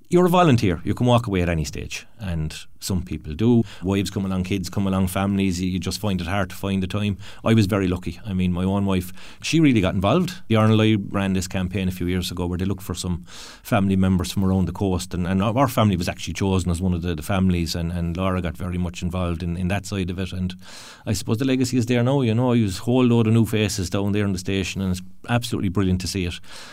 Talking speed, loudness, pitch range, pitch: 265 wpm, -22 LUFS, 90-105 Hz, 95 Hz